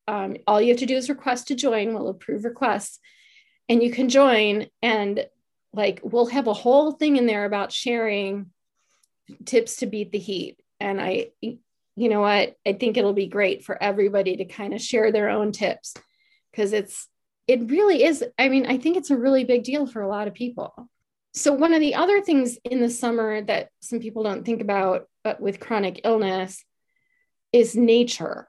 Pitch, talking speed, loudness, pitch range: 235 Hz, 195 wpm, -22 LUFS, 205-265 Hz